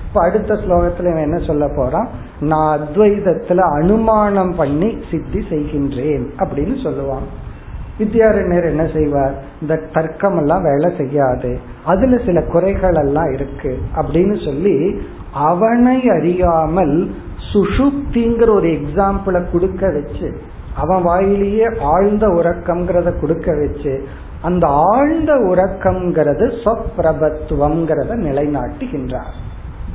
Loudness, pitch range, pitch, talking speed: -16 LUFS, 150-195 Hz, 170 Hz, 90 wpm